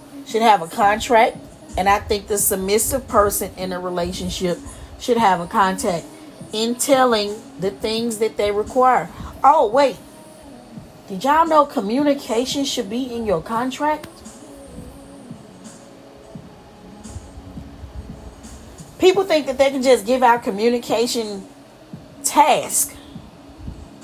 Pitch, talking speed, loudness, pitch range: 230 Hz, 110 wpm, -19 LUFS, 200-260 Hz